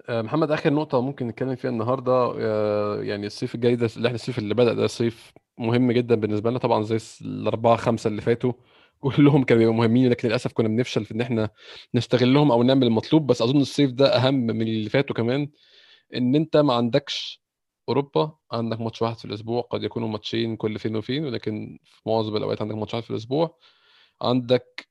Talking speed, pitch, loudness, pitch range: 185 wpm, 120 Hz, -23 LUFS, 110-130 Hz